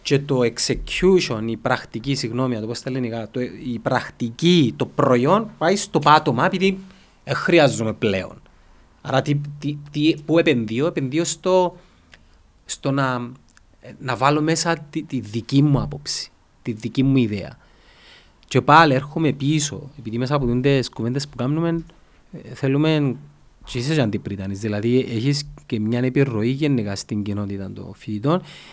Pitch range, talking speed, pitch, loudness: 115-150 Hz, 140 wpm, 135 Hz, -21 LUFS